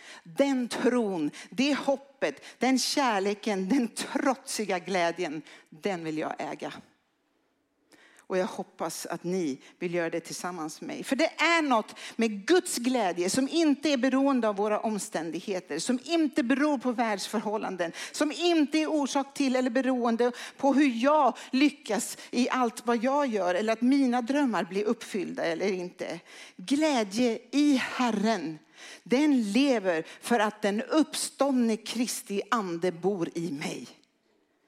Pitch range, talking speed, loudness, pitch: 200-275 Hz, 140 wpm, -28 LUFS, 245 Hz